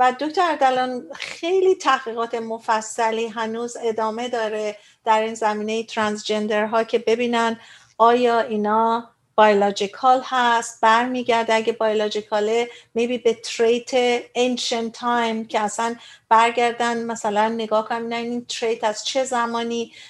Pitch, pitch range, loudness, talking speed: 230 Hz, 220-240 Hz, -21 LUFS, 115 wpm